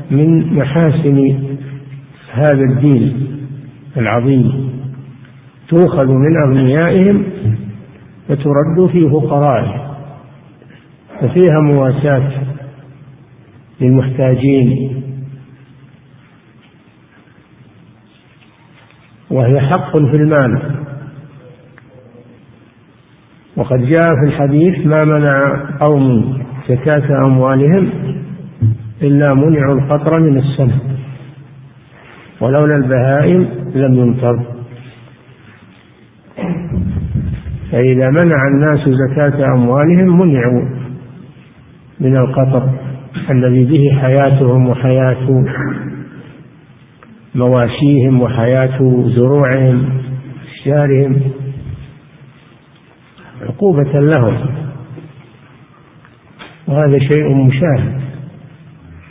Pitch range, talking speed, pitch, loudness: 130-145 Hz, 60 wpm, 135 Hz, -12 LUFS